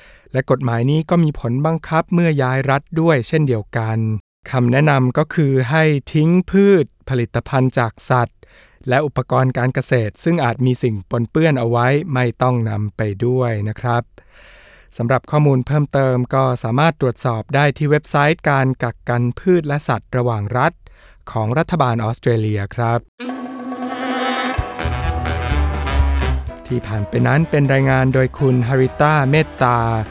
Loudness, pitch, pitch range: -17 LUFS, 130 Hz, 115-150 Hz